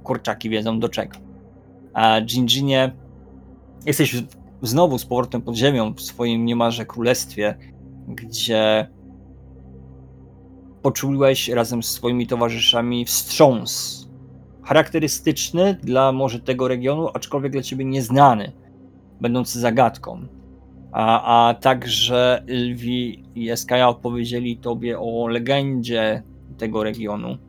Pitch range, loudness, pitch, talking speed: 95-125 Hz, -20 LUFS, 120 Hz, 100 wpm